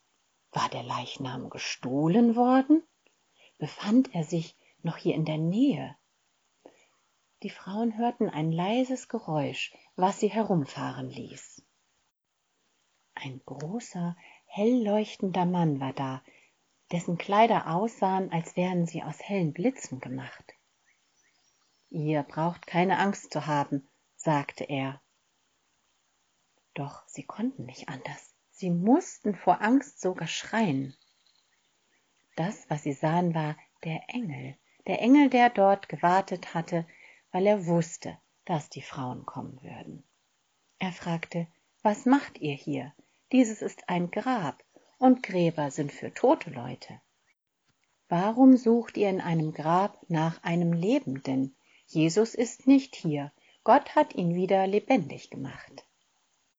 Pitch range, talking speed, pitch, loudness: 155-220 Hz, 120 wpm, 175 Hz, -28 LUFS